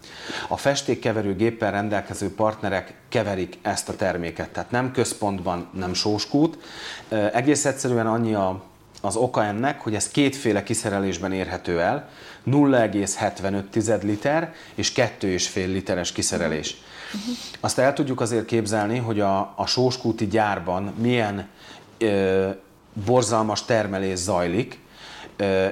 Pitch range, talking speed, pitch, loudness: 95-120 Hz, 105 wpm, 105 Hz, -24 LUFS